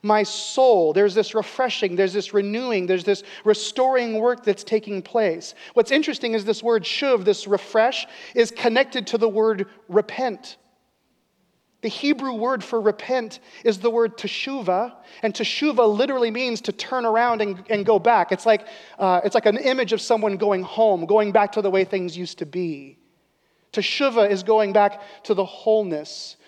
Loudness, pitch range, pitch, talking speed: -21 LUFS, 205-240 Hz, 220 Hz, 170 wpm